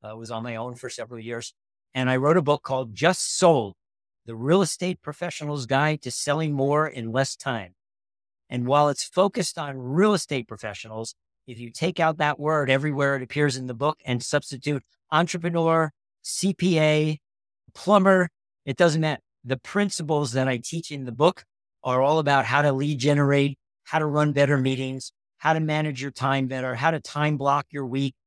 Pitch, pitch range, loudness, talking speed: 140 Hz, 125-155 Hz, -24 LUFS, 185 wpm